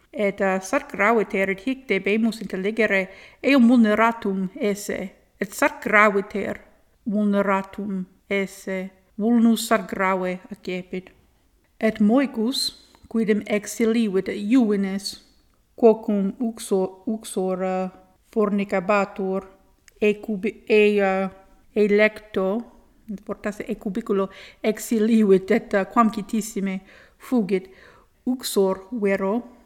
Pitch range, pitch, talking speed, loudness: 195-225 Hz, 210 Hz, 90 wpm, -22 LUFS